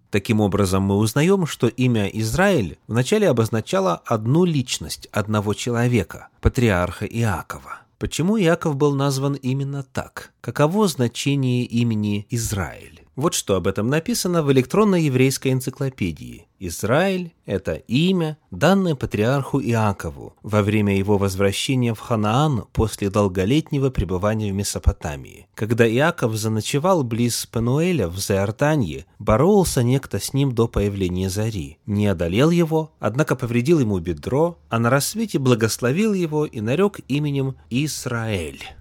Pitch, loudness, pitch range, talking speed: 120 Hz, -21 LUFS, 105-145 Hz, 125 wpm